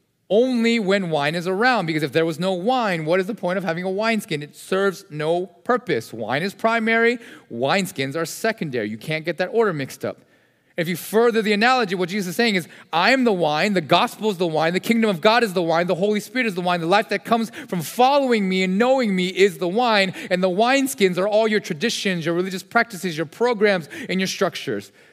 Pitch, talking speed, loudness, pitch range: 195 Hz, 230 wpm, -21 LUFS, 175-225 Hz